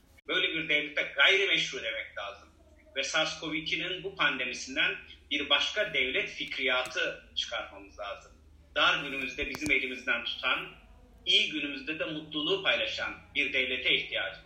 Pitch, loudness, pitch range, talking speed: 160 Hz, -29 LUFS, 140-210 Hz, 120 wpm